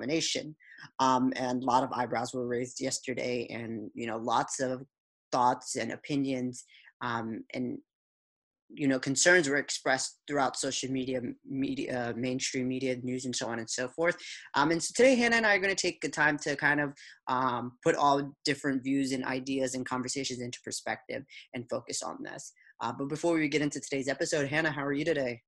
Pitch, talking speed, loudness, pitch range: 135 Hz, 190 wpm, -30 LUFS, 125-150 Hz